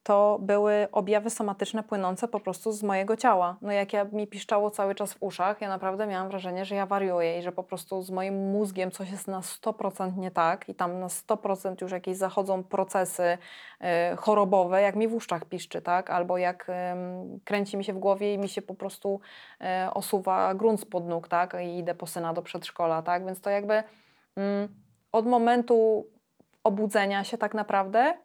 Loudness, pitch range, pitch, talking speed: -28 LUFS, 185-210 Hz, 195 Hz, 195 wpm